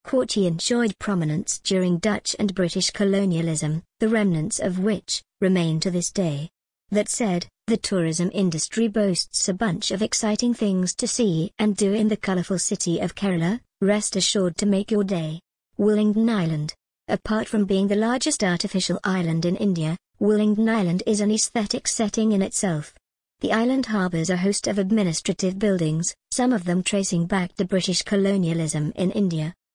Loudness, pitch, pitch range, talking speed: -23 LUFS, 195 Hz, 180-215 Hz, 160 wpm